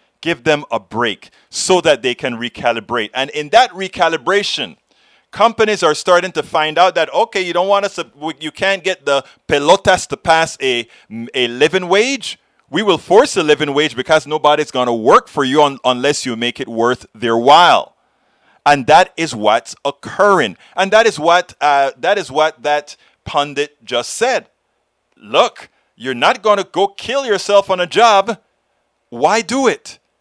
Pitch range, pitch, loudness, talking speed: 135-190 Hz, 155 Hz, -14 LUFS, 175 wpm